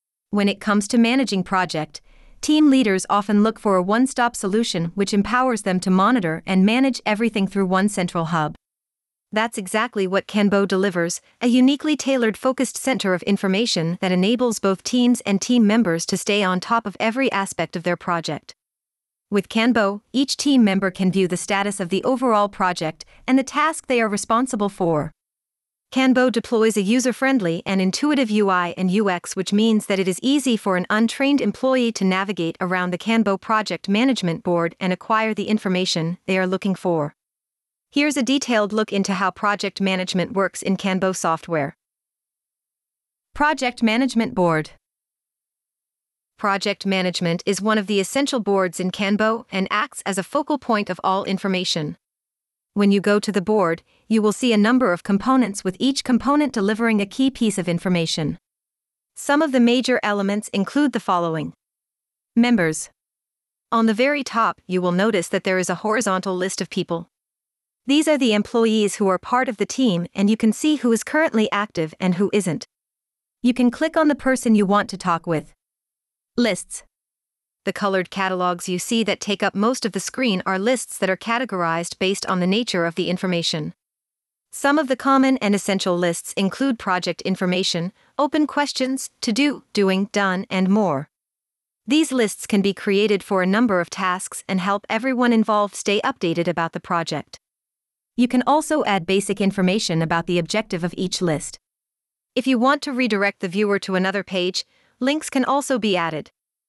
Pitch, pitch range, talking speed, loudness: 205 Hz, 185-240 Hz, 175 wpm, -20 LUFS